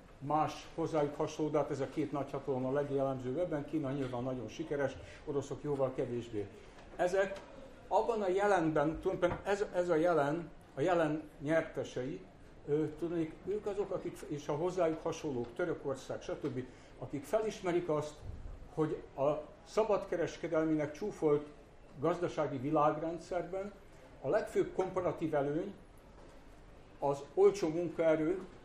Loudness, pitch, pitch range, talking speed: -35 LUFS, 155 Hz, 145-175 Hz, 120 wpm